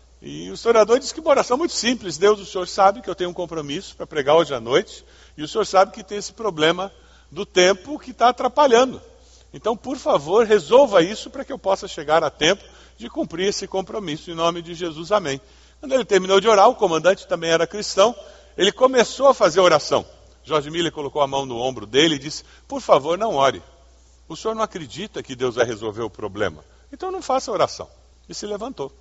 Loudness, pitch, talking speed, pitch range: -20 LUFS, 200 Hz, 215 wpm, 165-250 Hz